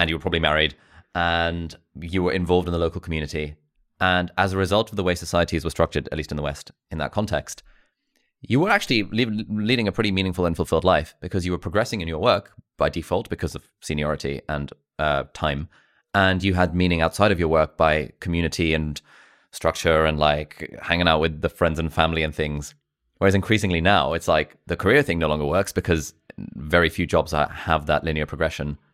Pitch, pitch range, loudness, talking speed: 85 Hz, 75-90 Hz, -22 LUFS, 205 wpm